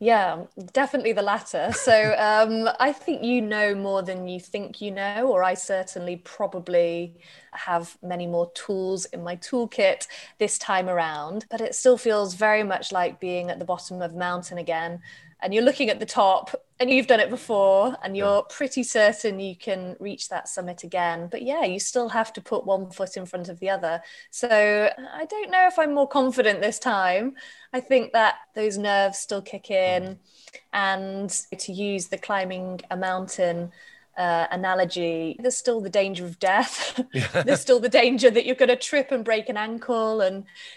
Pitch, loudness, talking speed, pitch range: 200 Hz, -24 LUFS, 185 wpm, 185-240 Hz